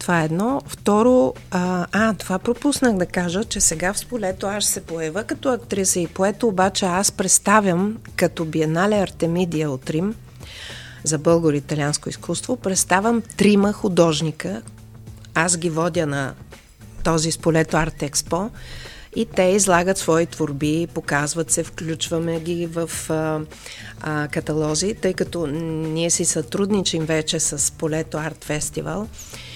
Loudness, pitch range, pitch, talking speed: -21 LUFS, 155-195 Hz, 170 Hz, 135 wpm